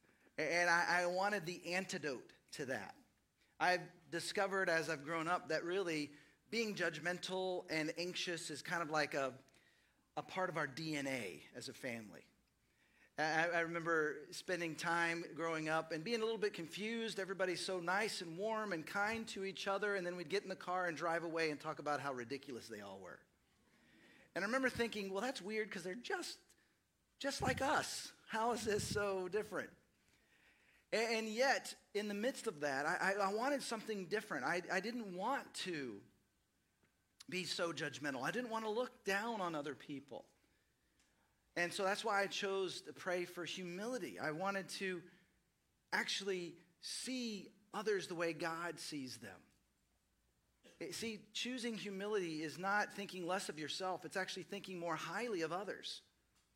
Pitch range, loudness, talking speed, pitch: 165-210 Hz, -41 LUFS, 165 wpm, 185 Hz